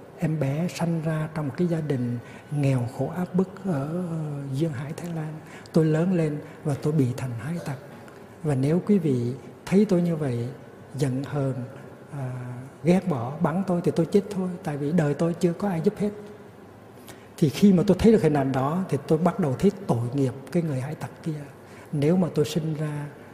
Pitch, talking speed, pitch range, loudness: 155 Hz, 210 wpm, 135-175 Hz, -25 LUFS